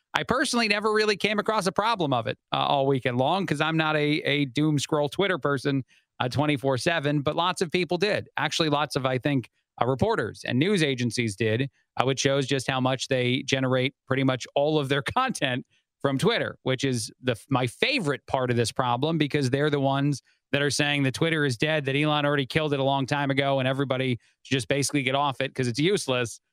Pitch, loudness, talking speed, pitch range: 140 Hz, -25 LUFS, 220 wpm, 130-155 Hz